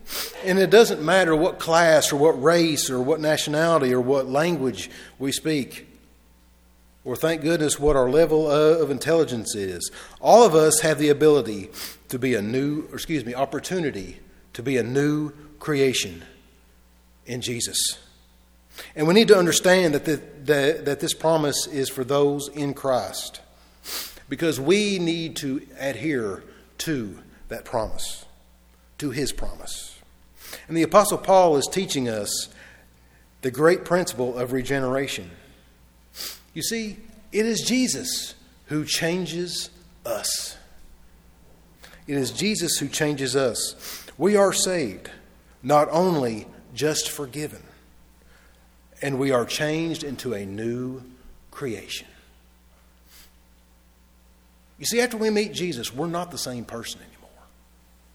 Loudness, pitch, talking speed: -22 LUFS, 135 Hz, 130 wpm